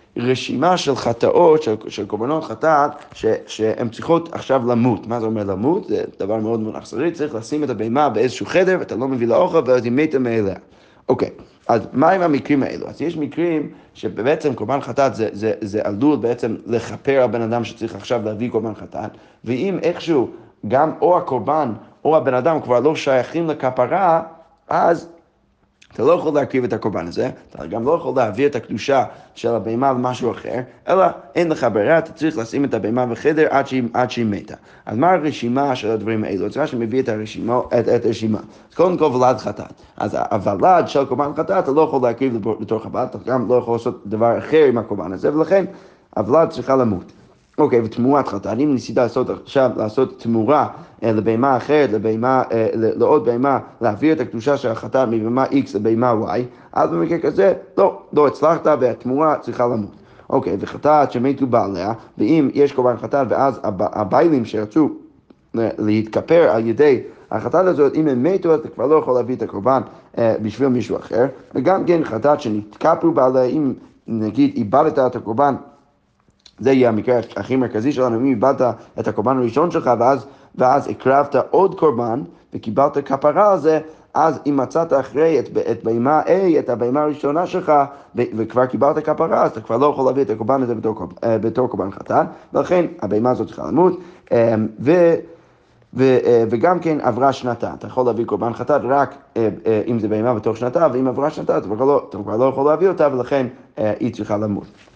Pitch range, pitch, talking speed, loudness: 115-150 Hz, 130 Hz, 175 wpm, -18 LUFS